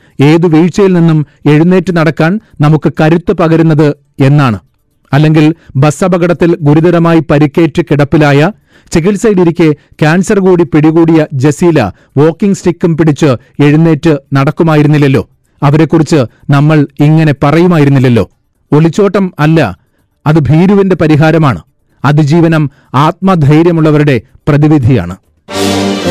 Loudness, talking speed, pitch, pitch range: -8 LUFS, 85 wpm, 155 Hz, 145-170 Hz